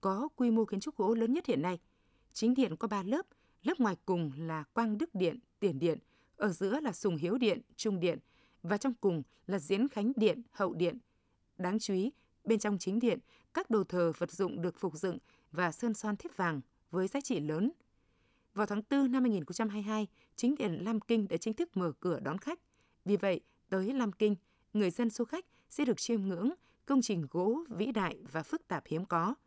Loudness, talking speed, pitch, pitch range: -34 LUFS, 210 wpm, 205 Hz, 180-235 Hz